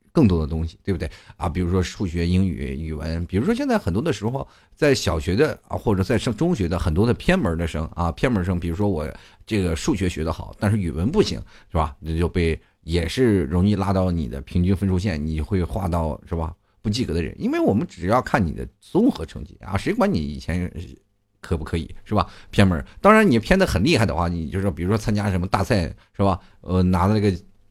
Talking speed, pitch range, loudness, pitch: 330 characters per minute, 85-100 Hz, -22 LUFS, 95 Hz